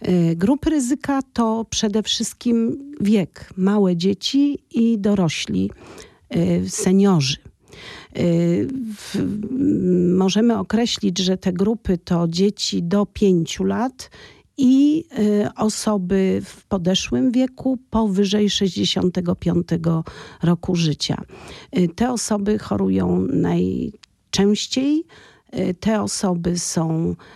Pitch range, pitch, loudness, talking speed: 175-225 Hz, 200 Hz, -20 LUFS, 80 wpm